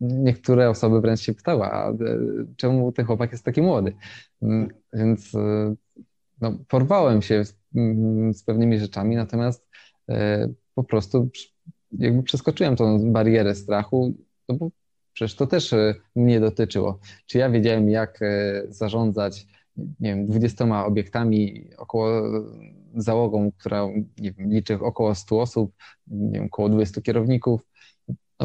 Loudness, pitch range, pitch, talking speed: -23 LUFS, 105-120 Hz, 110 Hz, 120 wpm